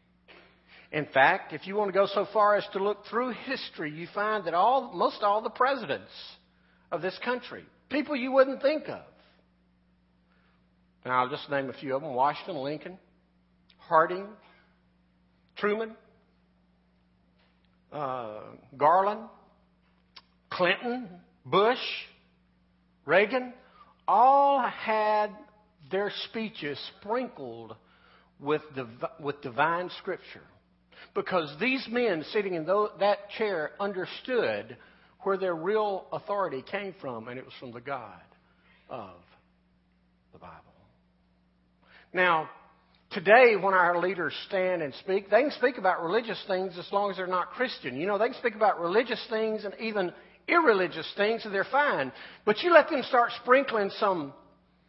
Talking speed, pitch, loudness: 135 wpm, 190 Hz, -28 LUFS